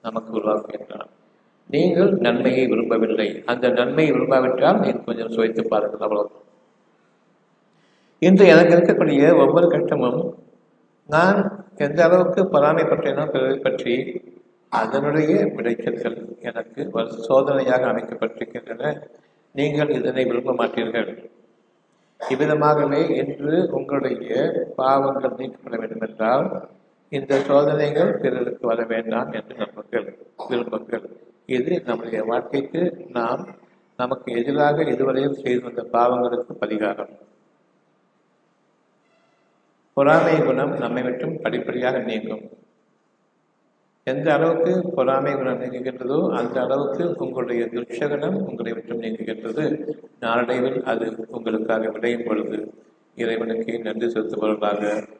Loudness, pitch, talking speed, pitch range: -21 LUFS, 125 Hz, 90 wpm, 115-145 Hz